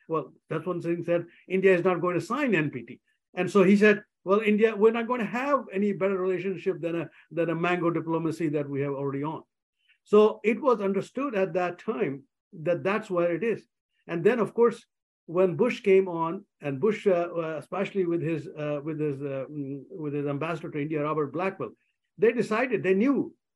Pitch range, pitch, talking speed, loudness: 160-205 Hz, 180 Hz, 200 wpm, -27 LUFS